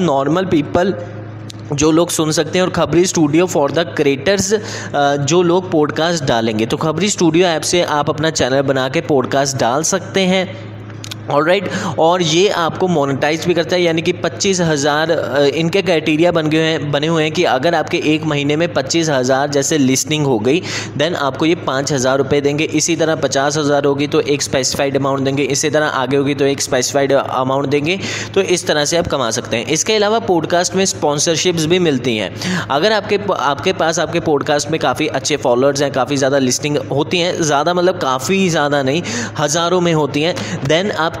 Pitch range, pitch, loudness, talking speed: 140-170 Hz, 155 Hz, -15 LUFS, 190 wpm